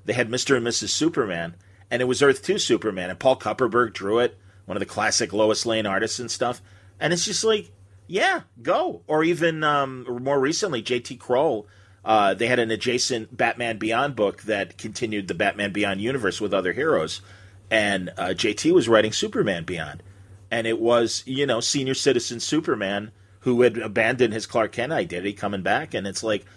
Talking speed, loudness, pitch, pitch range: 190 wpm, -23 LUFS, 115 Hz, 100-125 Hz